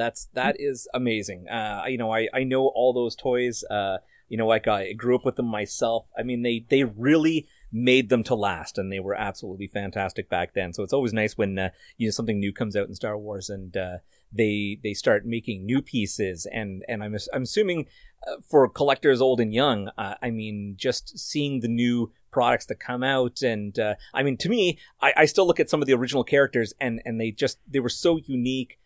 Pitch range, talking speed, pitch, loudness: 105-130 Hz, 220 wpm, 115 Hz, -25 LUFS